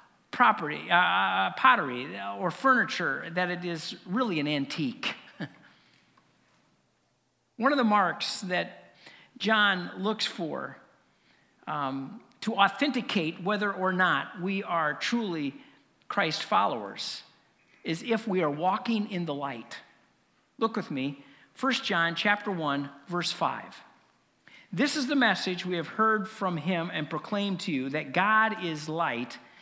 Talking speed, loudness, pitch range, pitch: 130 wpm, -28 LUFS, 160-215 Hz, 185 Hz